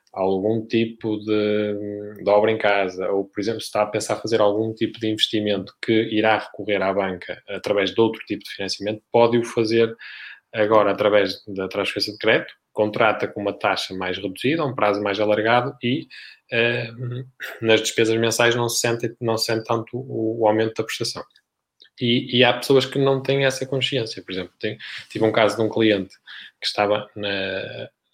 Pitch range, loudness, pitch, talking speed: 105-120 Hz, -21 LUFS, 110 Hz, 180 wpm